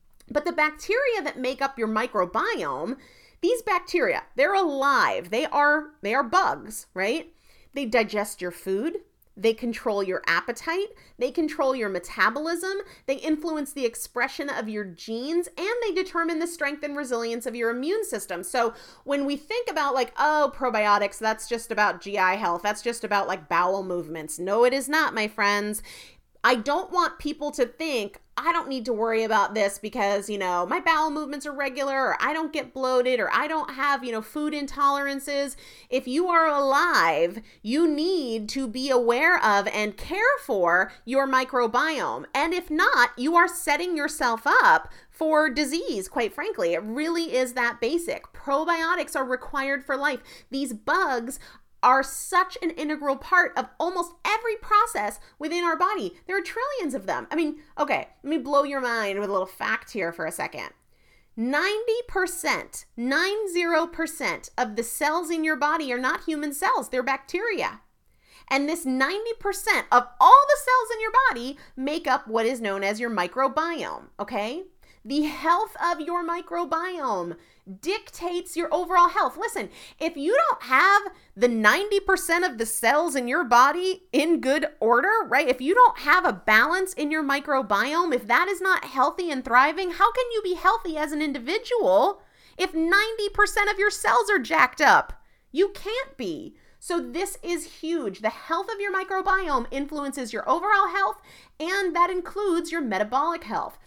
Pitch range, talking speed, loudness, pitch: 245-355 Hz, 170 wpm, -24 LUFS, 295 Hz